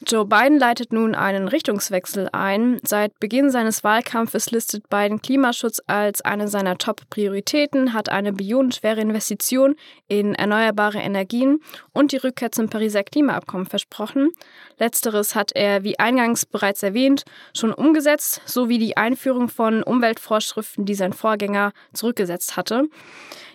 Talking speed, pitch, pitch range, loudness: 130 wpm, 220 Hz, 205-260 Hz, -20 LUFS